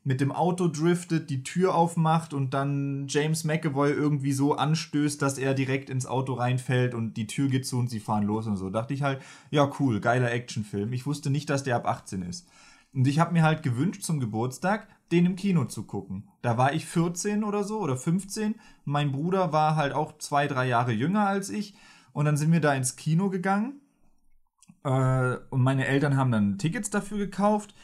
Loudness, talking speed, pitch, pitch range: -27 LUFS, 205 wpm, 145 Hz, 130-170 Hz